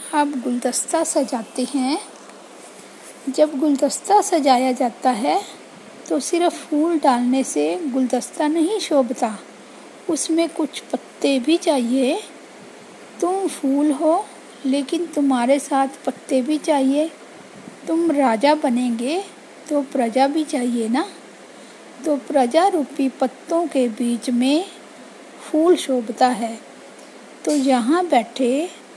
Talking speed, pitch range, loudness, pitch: 110 wpm, 260-325 Hz, -20 LUFS, 285 Hz